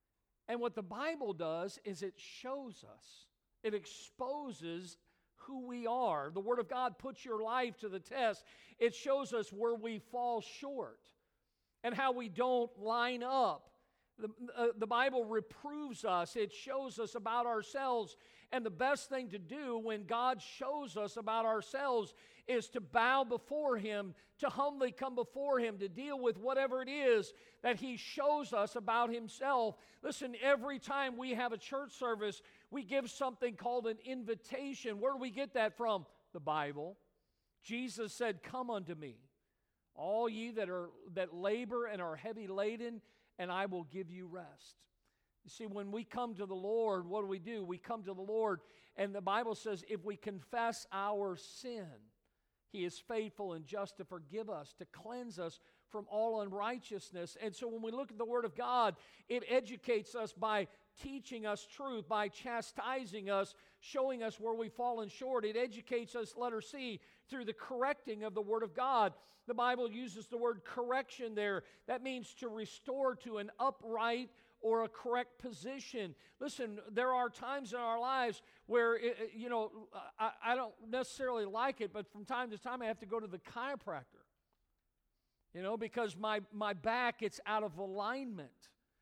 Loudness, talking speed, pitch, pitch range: -39 LUFS, 175 wpm, 230 Hz, 210-250 Hz